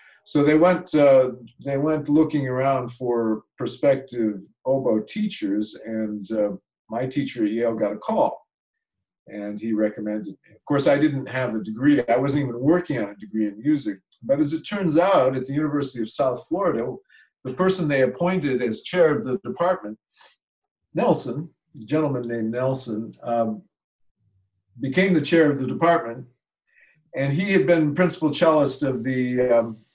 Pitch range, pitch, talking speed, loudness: 110-155 Hz, 130 Hz, 165 wpm, -22 LUFS